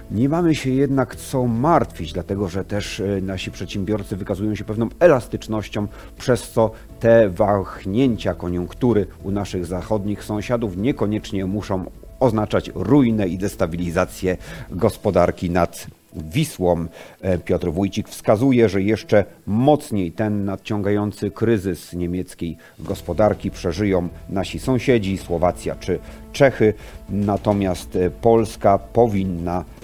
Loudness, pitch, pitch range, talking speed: -21 LUFS, 100 Hz, 90-110 Hz, 105 wpm